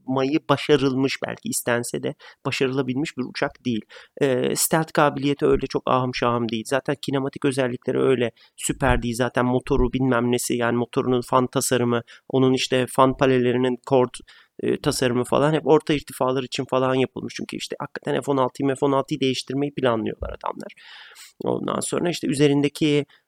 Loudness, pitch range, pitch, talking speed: -23 LUFS, 125-140 Hz, 130 Hz, 145 wpm